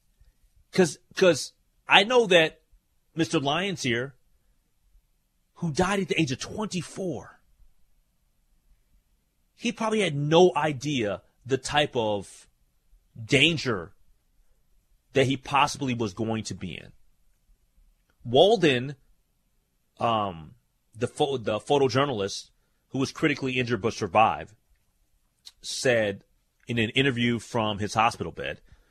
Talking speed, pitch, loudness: 105 wpm, 120 Hz, -25 LUFS